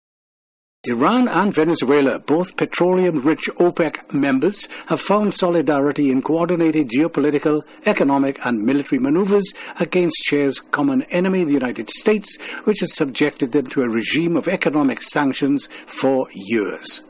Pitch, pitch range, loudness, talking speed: 165 Hz, 145-190 Hz, -19 LUFS, 125 wpm